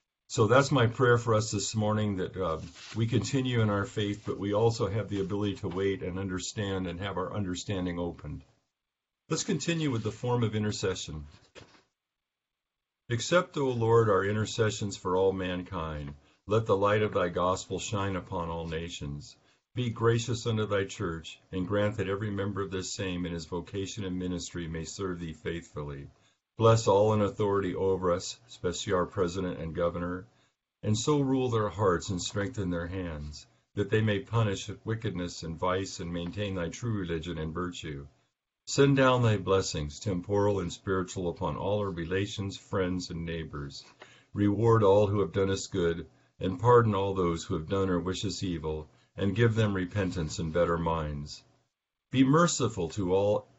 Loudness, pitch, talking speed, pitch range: -30 LUFS, 95 Hz, 170 wpm, 90-110 Hz